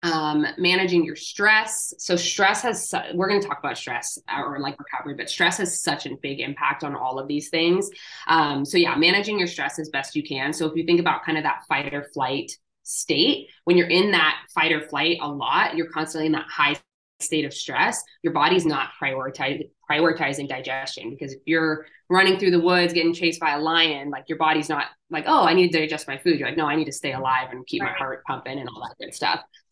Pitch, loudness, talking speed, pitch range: 160 Hz, -22 LUFS, 230 wpm, 145-175 Hz